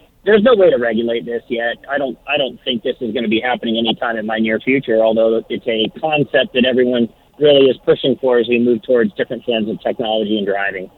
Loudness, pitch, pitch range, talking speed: -16 LUFS, 115 Hz, 110-125 Hz, 235 wpm